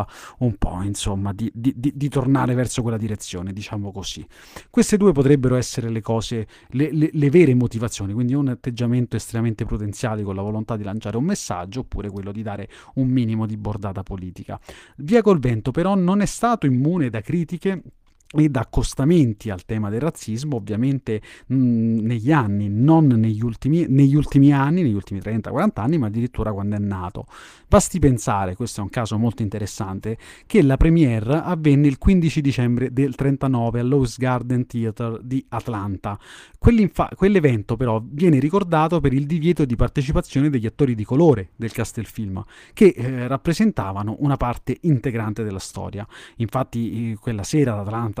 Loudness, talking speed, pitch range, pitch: -21 LUFS, 165 wpm, 110-145 Hz, 120 Hz